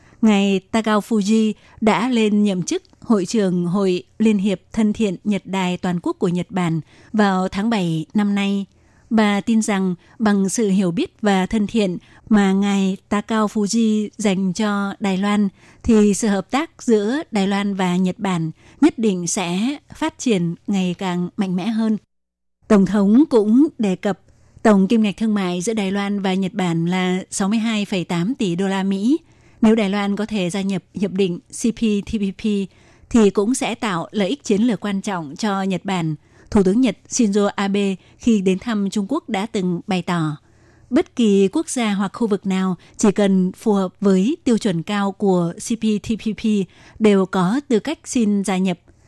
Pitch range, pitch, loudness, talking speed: 185-220 Hz, 200 Hz, -19 LUFS, 180 wpm